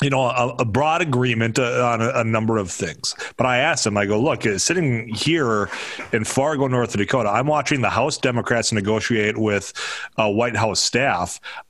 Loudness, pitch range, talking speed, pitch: -20 LUFS, 110-130 Hz, 195 wpm, 120 Hz